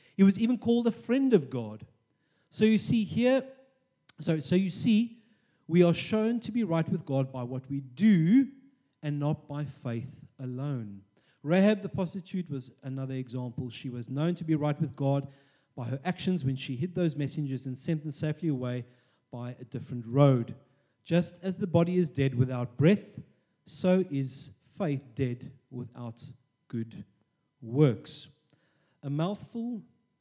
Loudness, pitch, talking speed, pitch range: -29 LUFS, 145 Hz, 160 wpm, 130-185 Hz